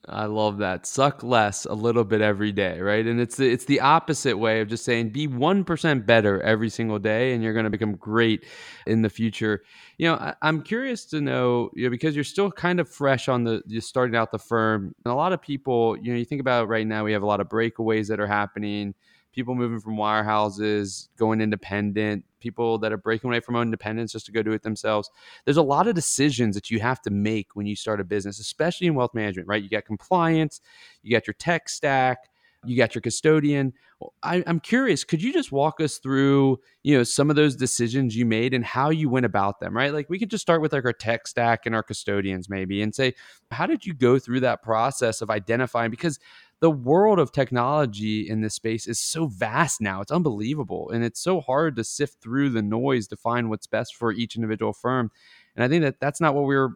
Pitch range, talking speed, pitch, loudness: 110-140 Hz, 230 wpm, 115 Hz, -24 LUFS